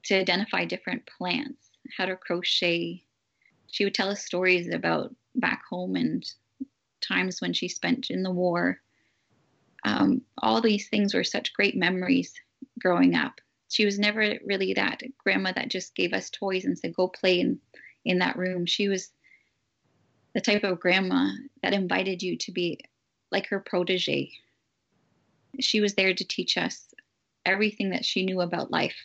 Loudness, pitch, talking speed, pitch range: -26 LUFS, 190 Hz, 160 wpm, 180-215 Hz